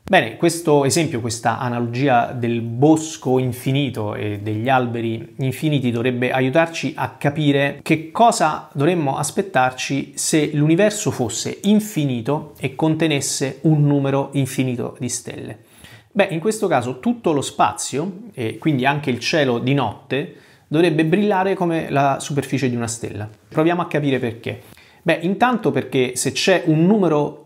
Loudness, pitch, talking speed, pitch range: -19 LUFS, 140 Hz, 140 wpm, 125-160 Hz